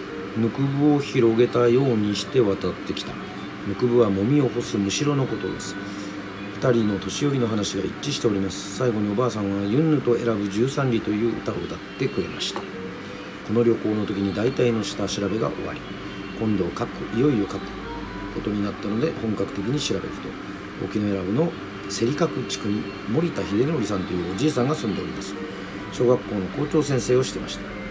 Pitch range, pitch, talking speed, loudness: 100-120 Hz, 105 Hz, 375 characters per minute, -24 LUFS